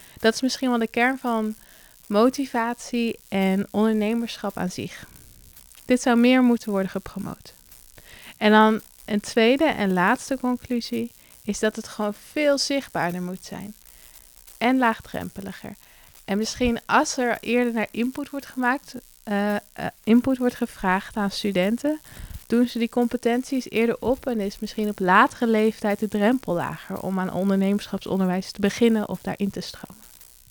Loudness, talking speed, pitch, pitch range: -23 LUFS, 145 wpm, 225 Hz, 200-245 Hz